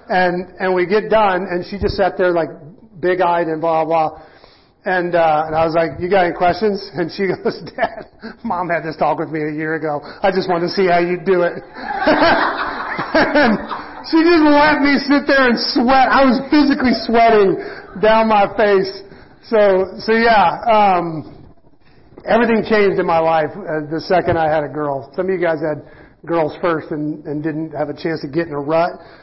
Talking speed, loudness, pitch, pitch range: 200 wpm, -16 LUFS, 180 Hz, 160-215 Hz